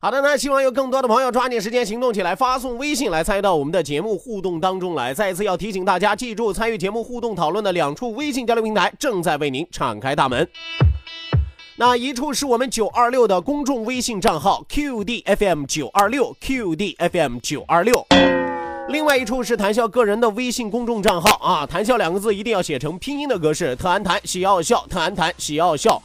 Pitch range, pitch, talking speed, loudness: 185-250 Hz, 225 Hz, 335 characters per minute, -20 LUFS